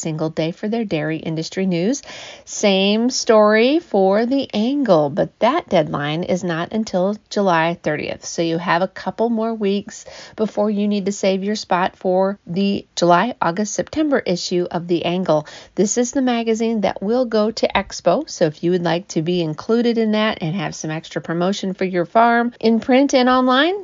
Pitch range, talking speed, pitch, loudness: 175-230 Hz, 185 wpm, 200 Hz, -19 LUFS